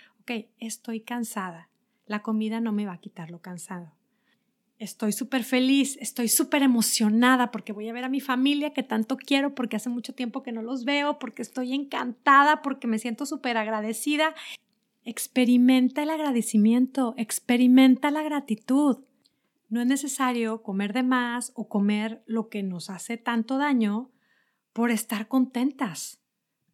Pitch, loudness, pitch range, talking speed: 240 Hz, -25 LUFS, 220-265 Hz, 150 wpm